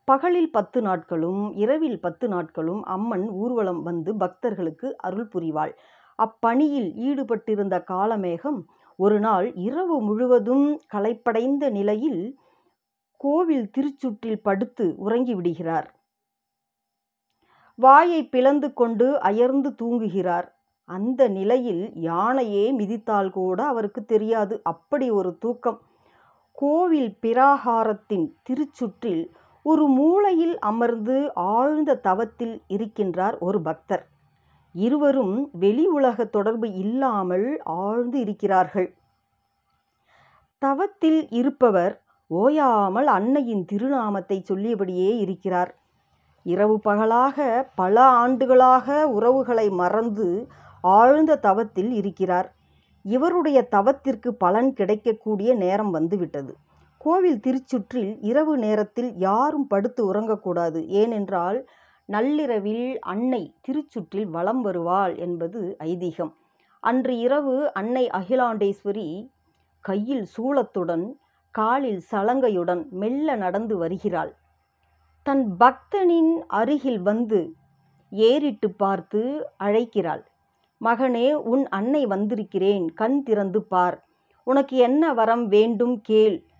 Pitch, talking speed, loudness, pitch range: 225 Hz, 85 wpm, -22 LUFS, 195-260 Hz